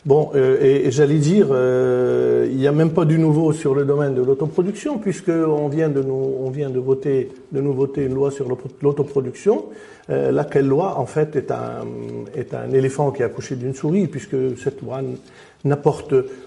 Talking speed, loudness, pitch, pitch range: 190 wpm, -19 LUFS, 140 Hz, 130-155 Hz